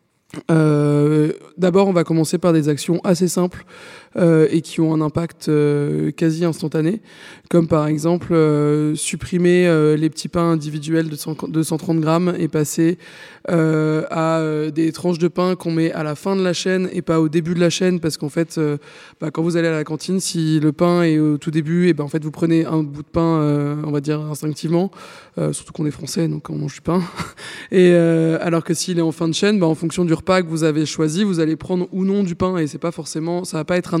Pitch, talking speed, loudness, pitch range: 165 Hz, 240 wpm, -18 LUFS, 155-175 Hz